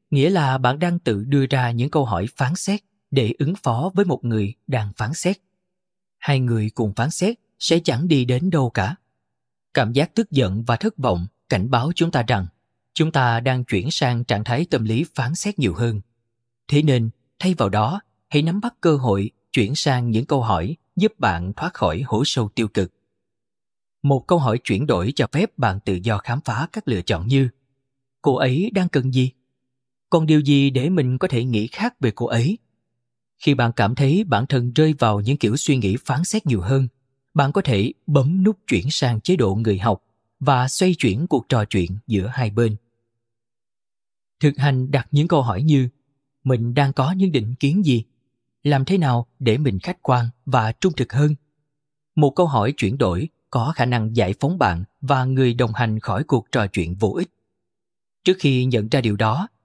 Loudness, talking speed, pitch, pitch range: -20 LUFS, 200 wpm, 130 Hz, 115-150 Hz